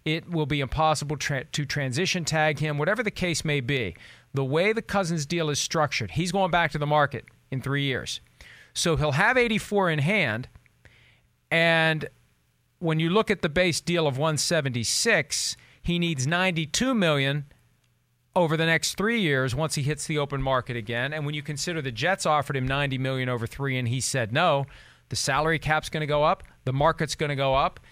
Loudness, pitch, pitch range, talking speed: -25 LUFS, 150 Hz, 135-165 Hz, 195 wpm